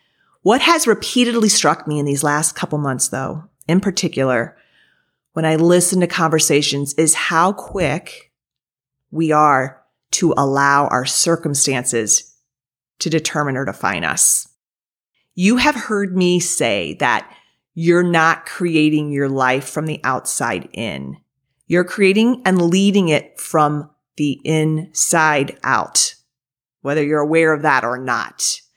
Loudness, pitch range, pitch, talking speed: -16 LUFS, 140-175 Hz, 155 Hz, 130 wpm